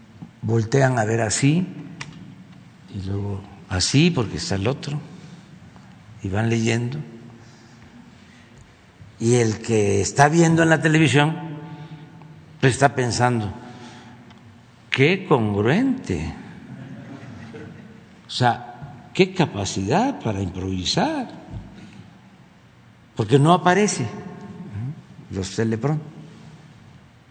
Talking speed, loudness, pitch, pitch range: 85 wpm, -21 LUFS, 120 Hz, 115-150 Hz